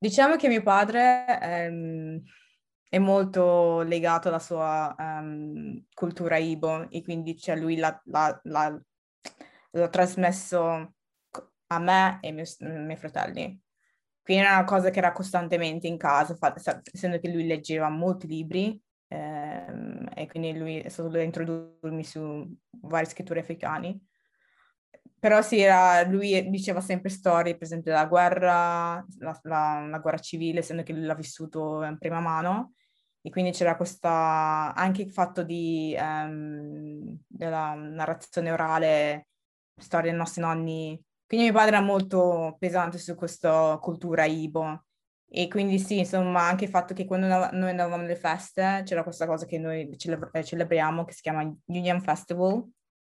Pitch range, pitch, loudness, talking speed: 160-185 Hz, 170 Hz, -26 LUFS, 150 wpm